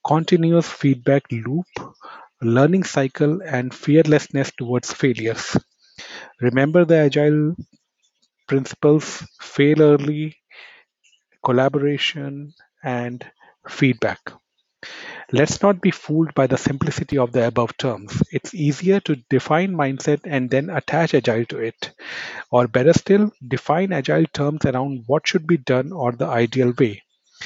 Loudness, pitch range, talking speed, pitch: -19 LUFS, 130-155 Hz, 120 wpm, 140 Hz